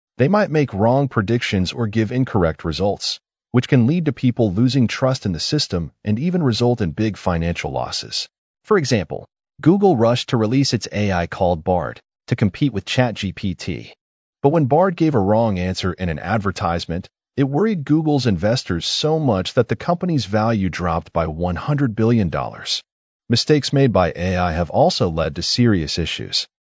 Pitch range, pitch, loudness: 90-140 Hz, 115 Hz, -19 LUFS